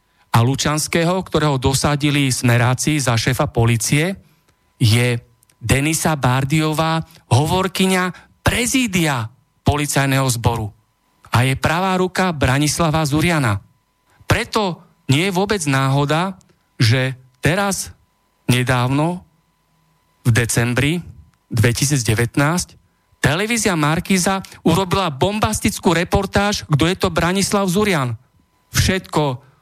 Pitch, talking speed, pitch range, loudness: 150 Hz, 85 wpm, 125-180 Hz, -18 LUFS